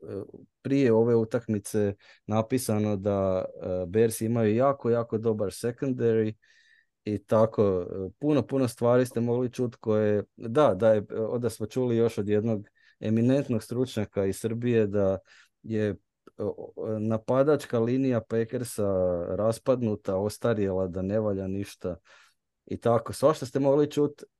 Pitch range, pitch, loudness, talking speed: 105-120 Hz, 110 Hz, -27 LUFS, 125 wpm